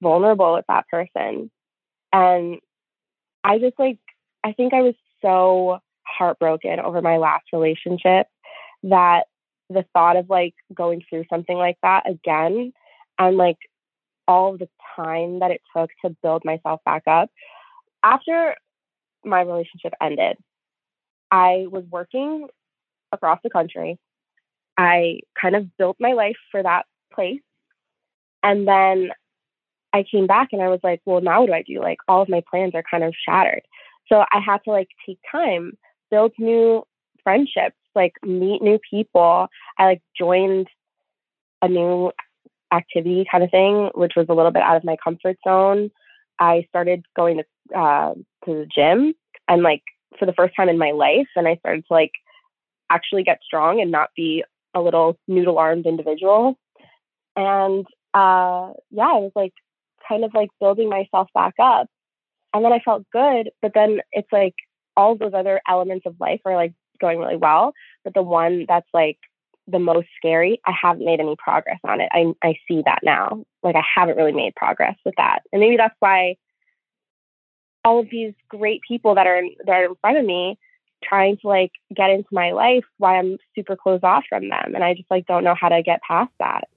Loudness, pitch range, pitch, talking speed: -19 LUFS, 175-205 Hz, 185 Hz, 175 wpm